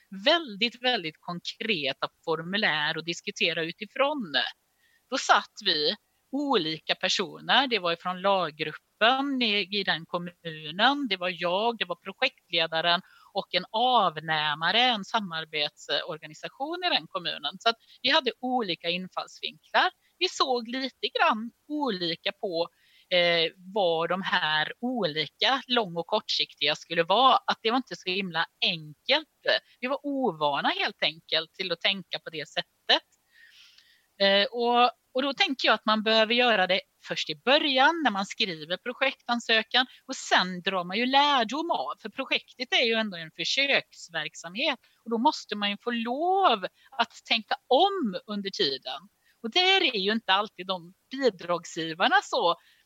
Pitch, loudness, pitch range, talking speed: 215 Hz, -26 LUFS, 175-260 Hz, 145 wpm